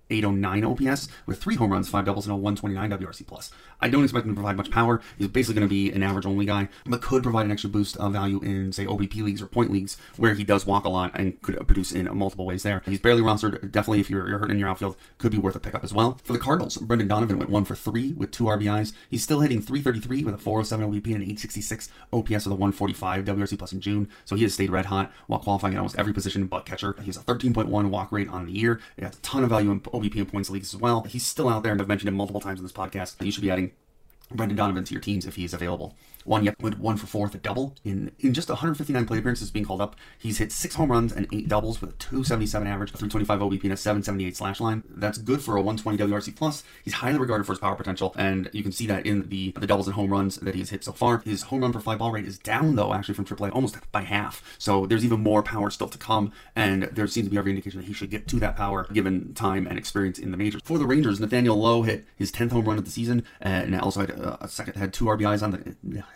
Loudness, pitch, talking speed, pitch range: -26 LUFS, 105 Hz, 275 wpm, 100-110 Hz